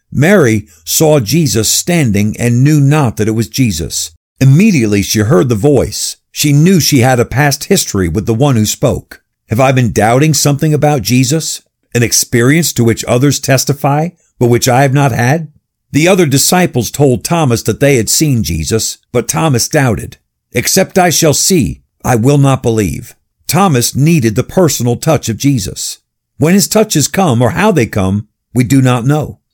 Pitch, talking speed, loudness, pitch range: 130 Hz, 175 wpm, -11 LUFS, 115-150 Hz